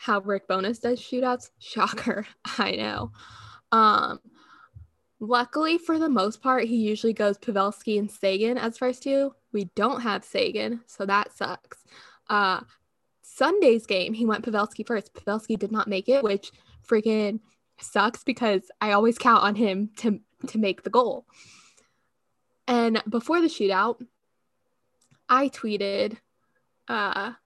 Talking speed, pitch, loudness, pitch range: 140 wpm, 225 Hz, -25 LUFS, 205-250 Hz